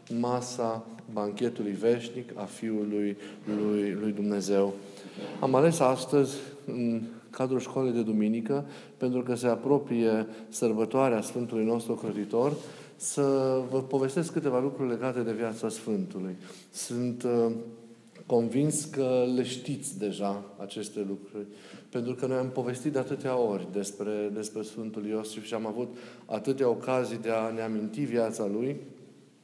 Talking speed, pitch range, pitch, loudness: 130 wpm, 110-130 Hz, 115 Hz, -30 LUFS